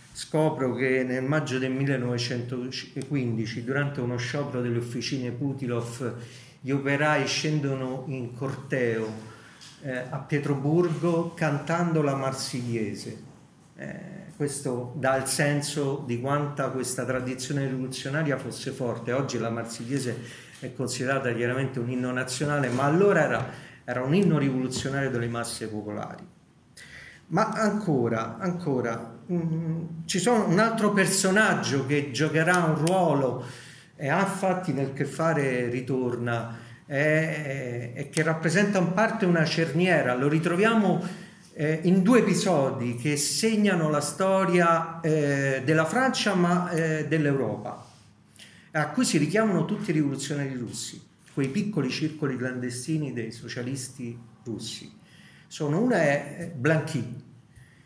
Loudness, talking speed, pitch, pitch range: -26 LUFS, 120 wpm, 140 Hz, 125-160 Hz